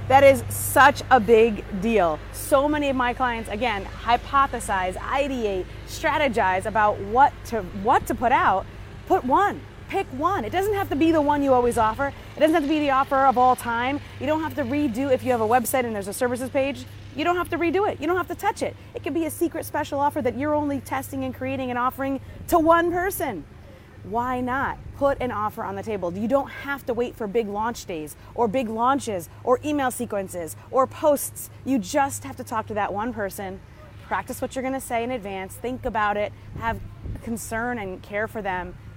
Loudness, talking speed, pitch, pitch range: -23 LUFS, 220 wpm, 255 Hz, 220-285 Hz